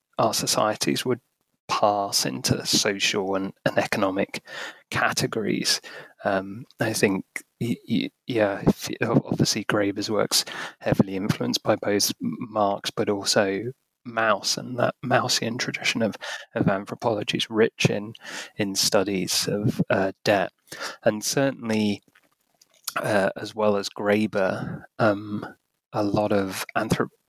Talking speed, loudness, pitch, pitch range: 115 wpm, -24 LUFS, 105 Hz, 100-105 Hz